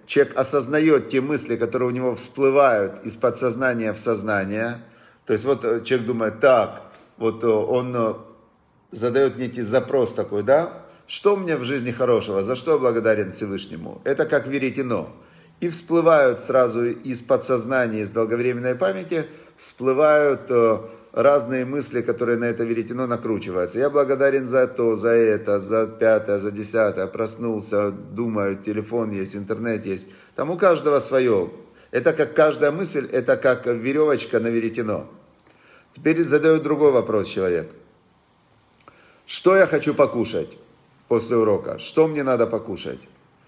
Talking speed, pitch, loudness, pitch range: 135 wpm, 120 Hz, -21 LUFS, 110-140 Hz